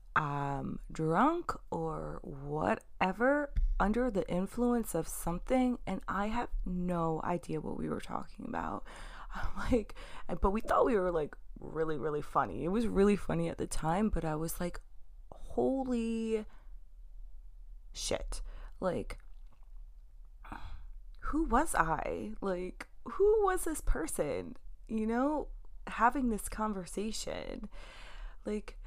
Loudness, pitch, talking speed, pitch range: -34 LUFS, 200 Hz, 120 wpm, 165-245 Hz